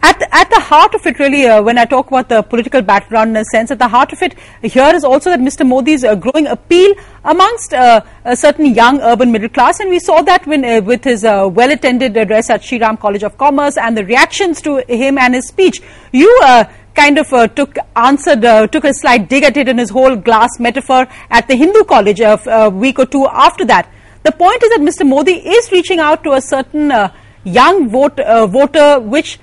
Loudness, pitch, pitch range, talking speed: -9 LUFS, 265 Hz, 235-310 Hz, 230 wpm